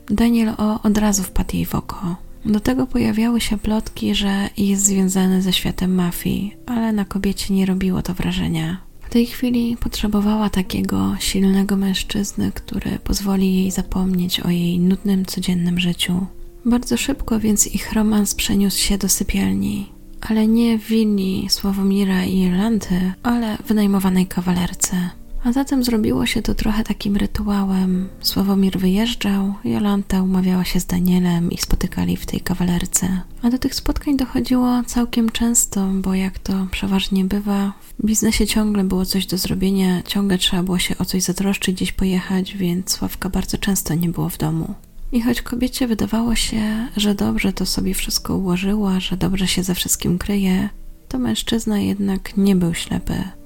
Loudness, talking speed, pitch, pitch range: -19 LUFS, 160 wpm, 195 Hz, 185-215 Hz